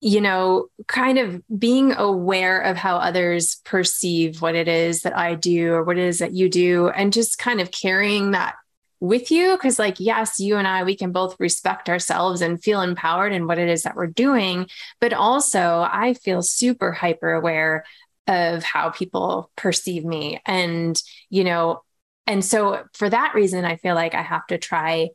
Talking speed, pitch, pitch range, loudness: 190 wpm, 185 Hz, 170-210 Hz, -20 LUFS